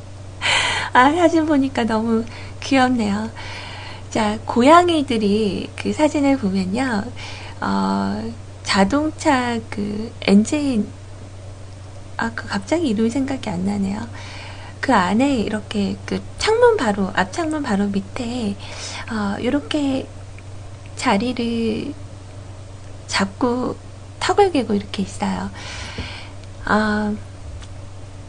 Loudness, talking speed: -20 LUFS, 180 characters per minute